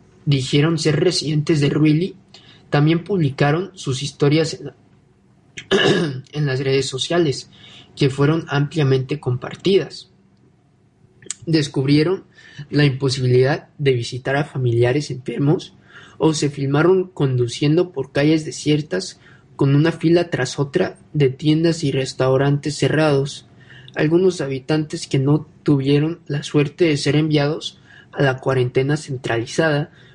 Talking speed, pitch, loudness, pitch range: 115 wpm, 145 Hz, -19 LUFS, 135-160 Hz